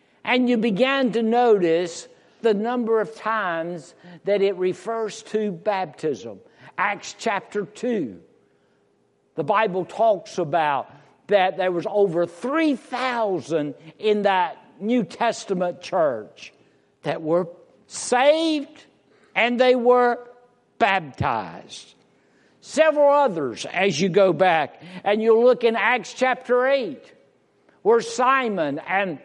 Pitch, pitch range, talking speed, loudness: 220 Hz, 185-245 Hz, 110 wpm, -22 LUFS